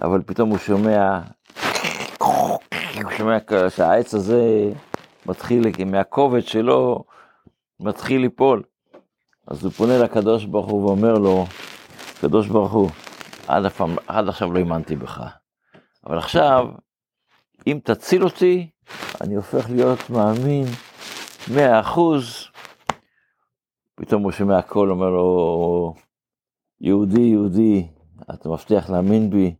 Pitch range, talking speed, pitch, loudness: 95-115 Hz, 110 wpm, 105 Hz, -19 LUFS